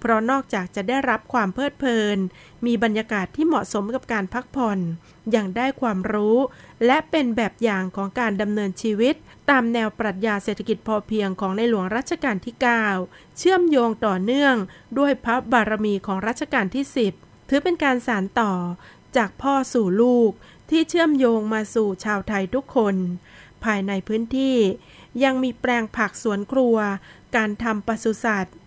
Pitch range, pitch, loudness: 210-255 Hz, 225 Hz, -22 LUFS